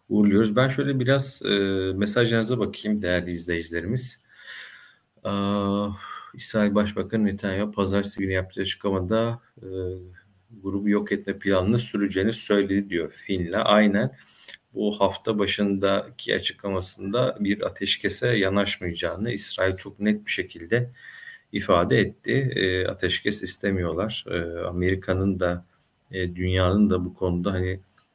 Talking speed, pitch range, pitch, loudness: 115 wpm, 95-105 Hz, 100 Hz, -25 LUFS